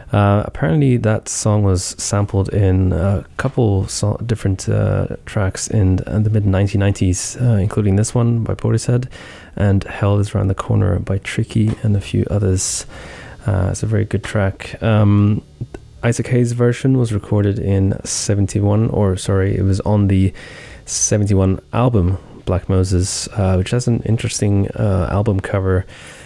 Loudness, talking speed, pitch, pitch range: -17 LUFS, 155 wpm, 100 Hz, 95-110 Hz